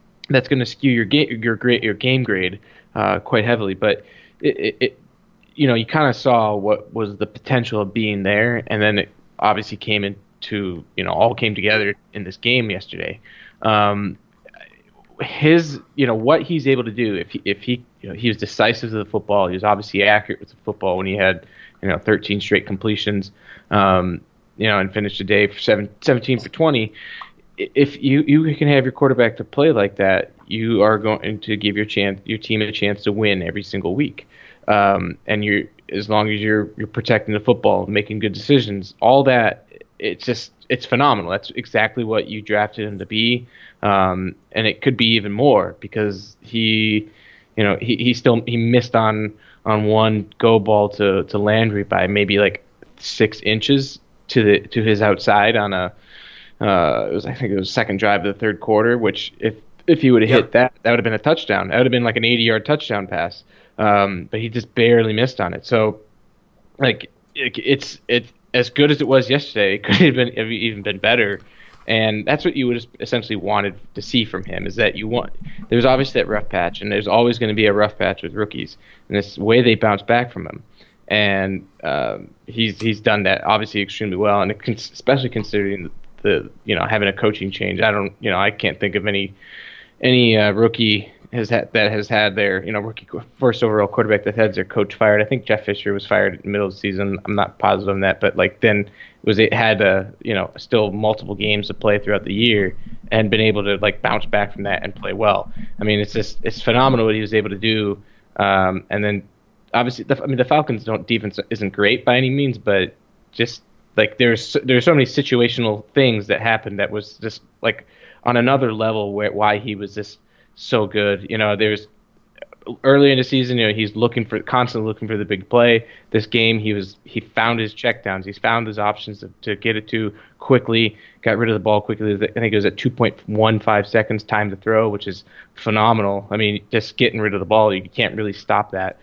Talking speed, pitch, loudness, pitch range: 220 wpm, 110 Hz, -18 LUFS, 105-120 Hz